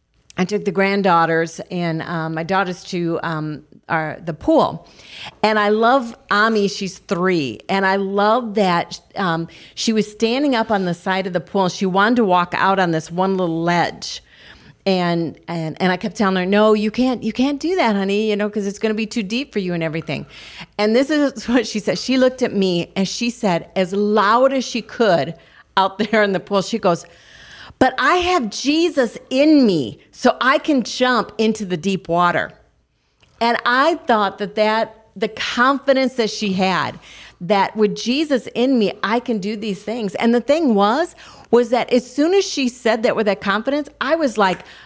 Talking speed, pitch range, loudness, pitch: 200 wpm, 185-240 Hz, -18 LUFS, 210 Hz